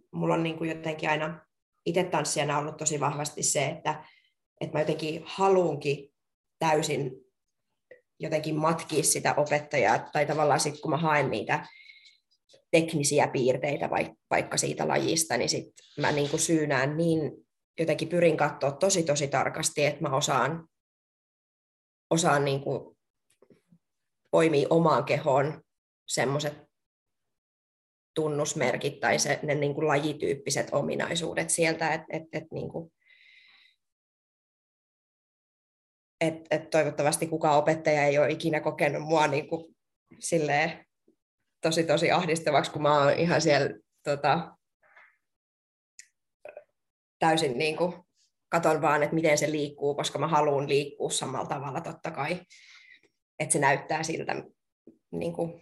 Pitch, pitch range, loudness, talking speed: 155 Hz, 145-165 Hz, -27 LUFS, 120 wpm